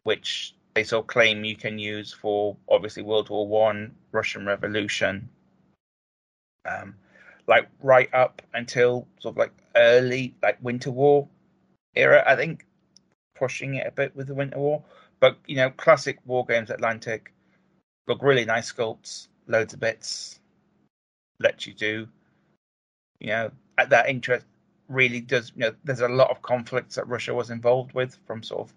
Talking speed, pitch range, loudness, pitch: 160 wpm, 110-130 Hz, -24 LUFS, 125 Hz